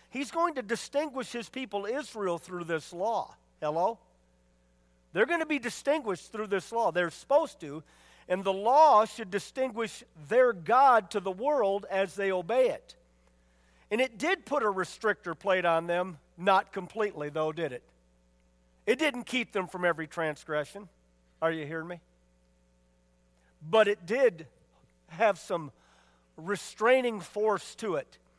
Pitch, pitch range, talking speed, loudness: 190 Hz, 150-230 Hz, 150 wpm, -29 LUFS